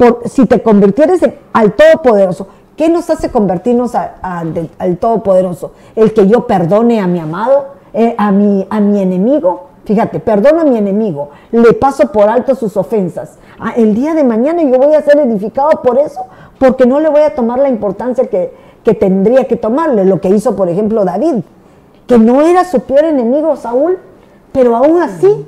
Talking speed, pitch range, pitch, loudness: 190 wpm, 205-280 Hz, 235 Hz, -10 LUFS